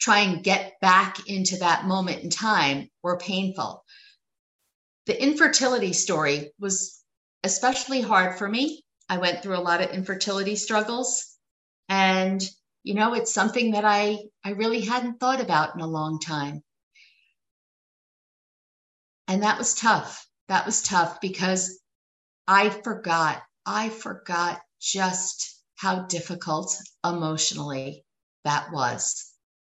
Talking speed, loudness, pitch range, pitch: 125 wpm, -24 LUFS, 175-215 Hz, 190 Hz